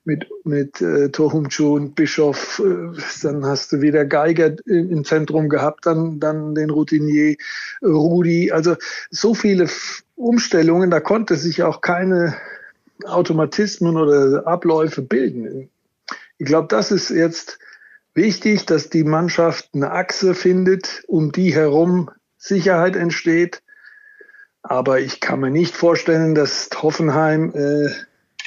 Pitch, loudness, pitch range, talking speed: 165 Hz, -18 LUFS, 155-180 Hz, 120 wpm